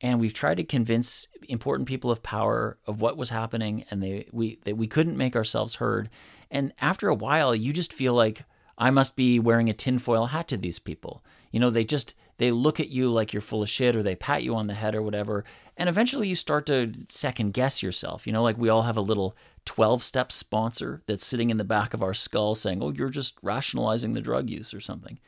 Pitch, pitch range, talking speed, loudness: 115 Hz, 105-130 Hz, 235 wpm, -26 LUFS